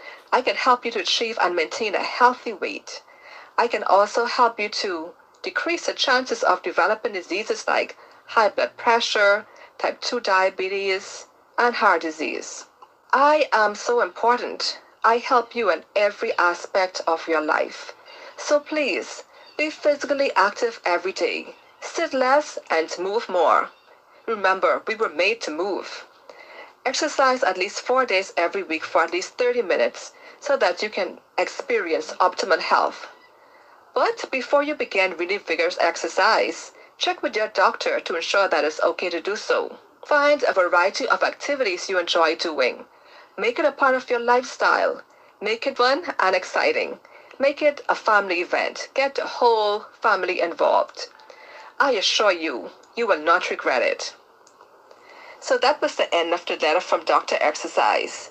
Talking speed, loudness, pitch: 155 wpm, -22 LUFS, 300 Hz